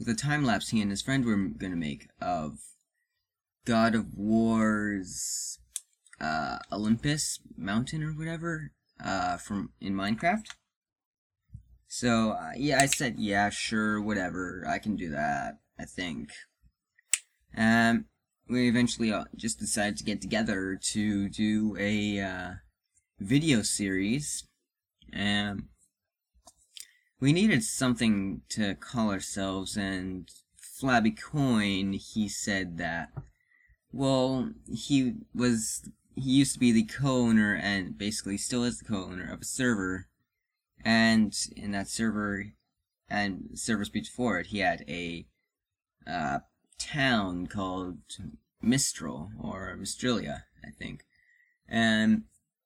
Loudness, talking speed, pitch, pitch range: -29 LUFS, 120 wpm, 110 Hz, 100-125 Hz